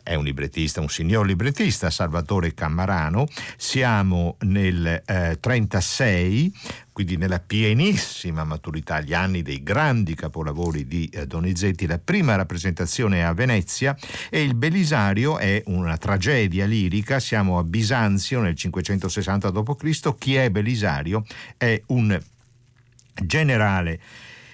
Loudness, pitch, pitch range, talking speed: -22 LUFS, 100 Hz, 85-120 Hz, 120 wpm